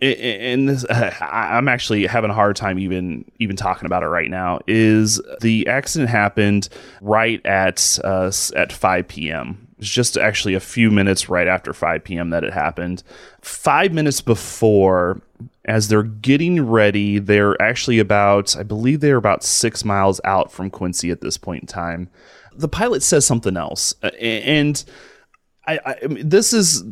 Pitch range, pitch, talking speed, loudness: 95-120 Hz, 105 Hz, 165 wpm, -18 LUFS